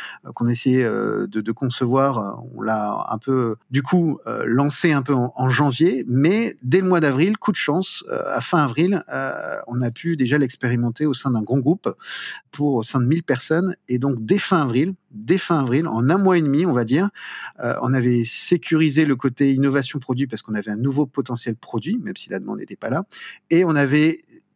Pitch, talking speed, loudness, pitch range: 140 Hz, 205 wpm, -20 LUFS, 125-165 Hz